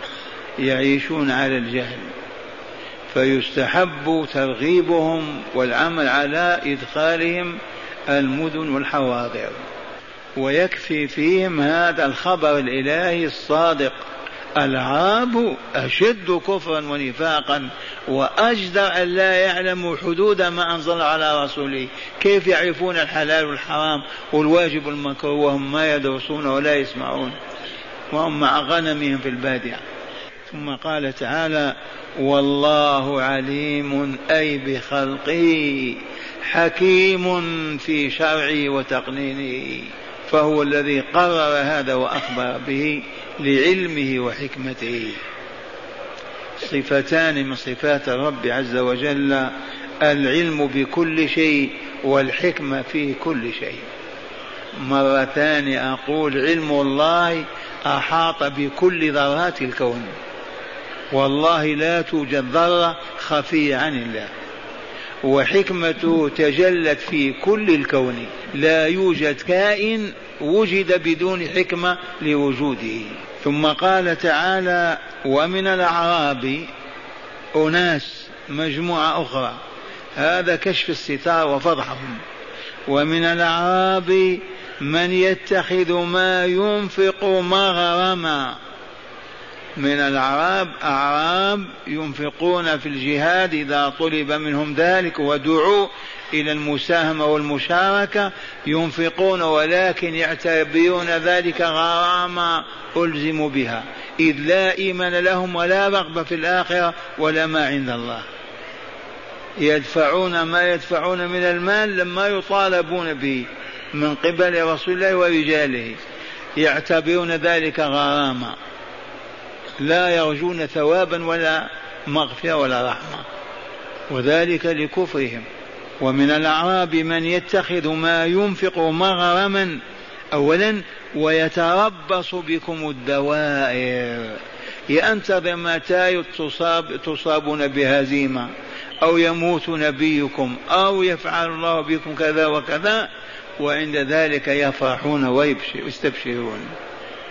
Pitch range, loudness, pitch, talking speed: 140-175 Hz, -19 LUFS, 155 Hz, 85 wpm